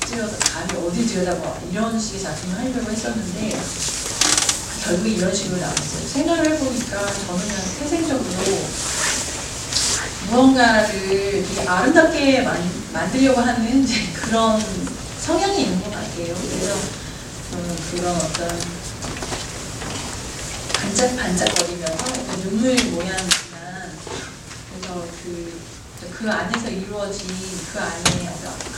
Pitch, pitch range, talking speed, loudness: 200 Hz, 175-245 Hz, 235 characters per minute, -21 LUFS